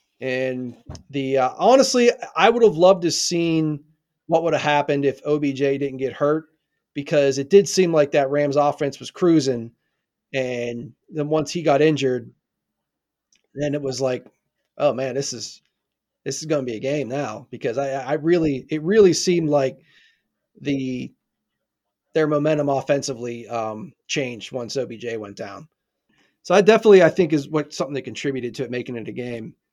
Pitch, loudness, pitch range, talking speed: 145 Hz, -21 LUFS, 130-155 Hz, 170 wpm